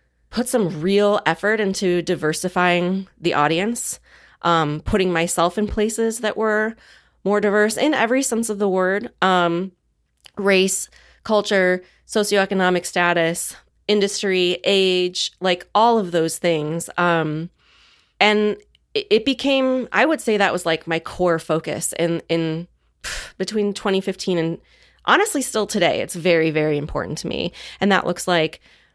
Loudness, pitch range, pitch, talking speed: -20 LUFS, 170-210 Hz, 185 Hz, 135 wpm